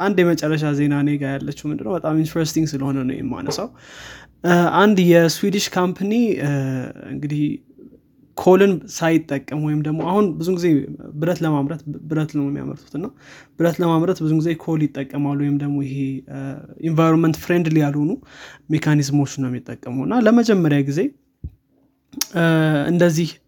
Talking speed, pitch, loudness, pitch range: 120 wpm, 155 Hz, -19 LUFS, 145-170 Hz